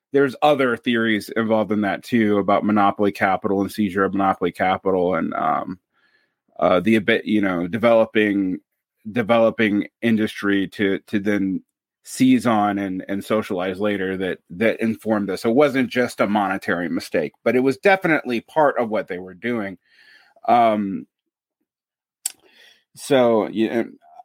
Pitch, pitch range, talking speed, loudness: 110 Hz, 100-120 Hz, 145 wpm, -20 LUFS